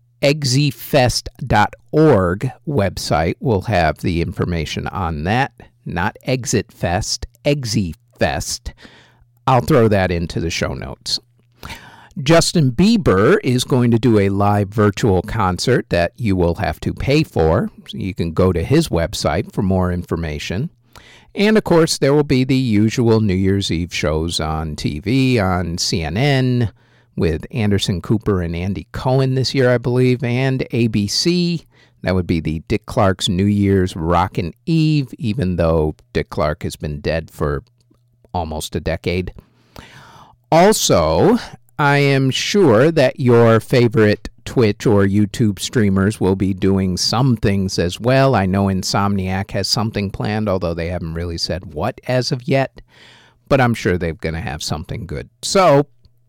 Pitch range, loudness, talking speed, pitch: 90-130 Hz, -17 LUFS, 145 wpm, 110 Hz